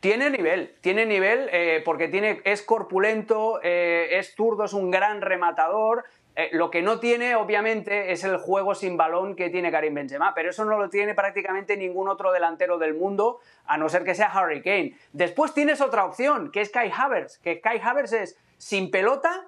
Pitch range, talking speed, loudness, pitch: 180-220 Hz, 195 wpm, -24 LUFS, 195 Hz